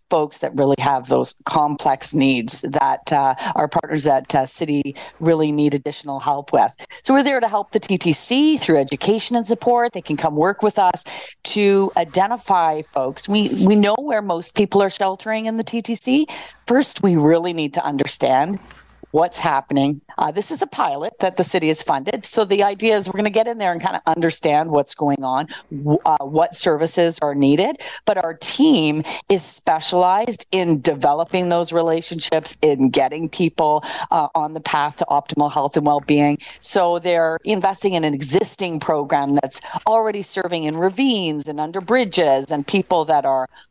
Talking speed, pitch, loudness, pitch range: 175 wpm, 165 Hz, -18 LUFS, 150-200 Hz